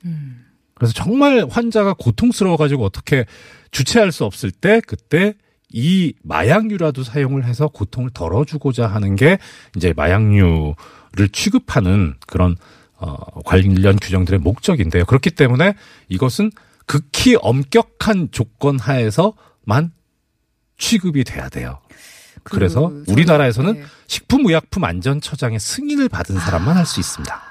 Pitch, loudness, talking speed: 135 Hz, -16 LUFS, 295 characters per minute